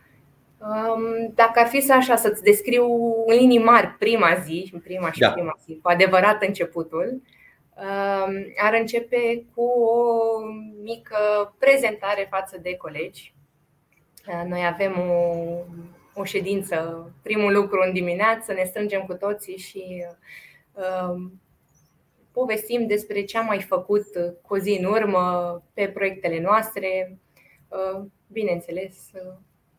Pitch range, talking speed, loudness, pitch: 175-220 Hz, 110 wpm, -22 LUFS, 195 Hz